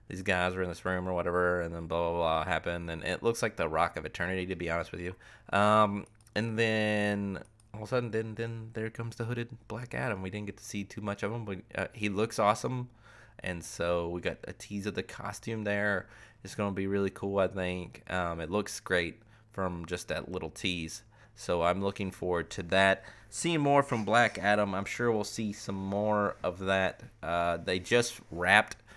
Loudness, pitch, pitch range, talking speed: -31 LUFS, 100 Hz, 90-110 Hz, 215 wpm